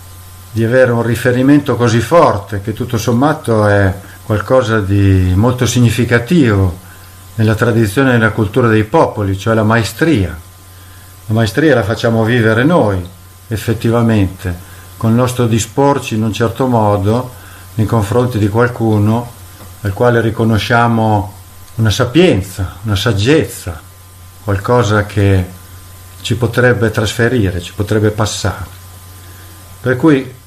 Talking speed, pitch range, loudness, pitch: 120 wpm, 95-120 Hz, -13 LUFS, 110 Hz